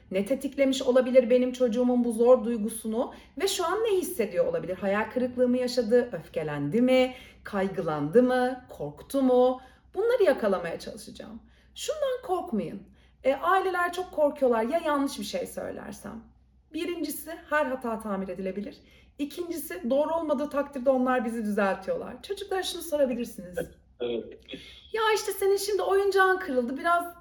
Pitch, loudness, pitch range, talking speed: 265 Hz, -27 LUFS, 240-345 Hz, 130 wpm